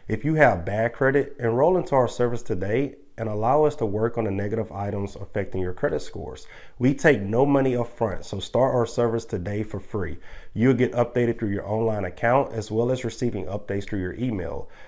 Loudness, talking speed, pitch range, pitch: -24 LUFS, 205 wpm, 100-125 Hz, 115 Hz